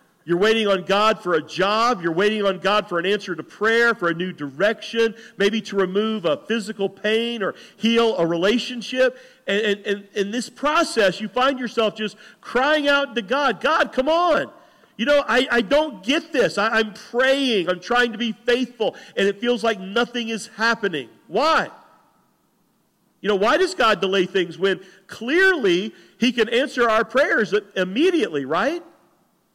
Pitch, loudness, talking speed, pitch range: 225 Hz, -21 LUFS, 175 wpm, 200-250 Hz